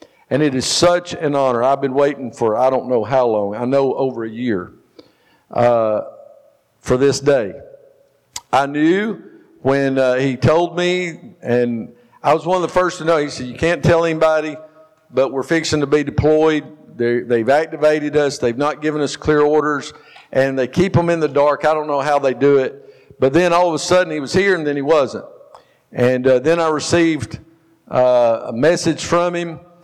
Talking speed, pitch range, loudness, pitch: 200 wpm, 130-165 Hz, -17 LUFS, 150 Hz